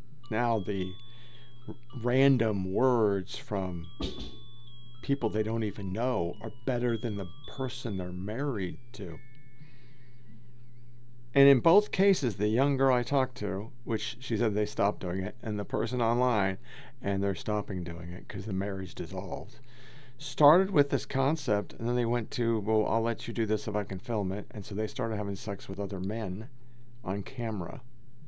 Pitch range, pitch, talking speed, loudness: 100-125 Hz, 115 Hz, 170 wpm, -30 LUFS